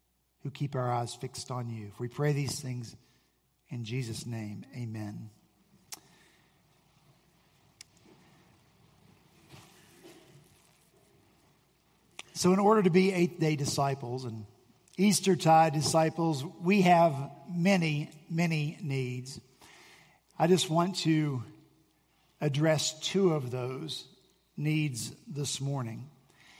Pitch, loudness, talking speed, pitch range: 150 Hz, -30 LUFS, 95 wpm, 125-165 Hz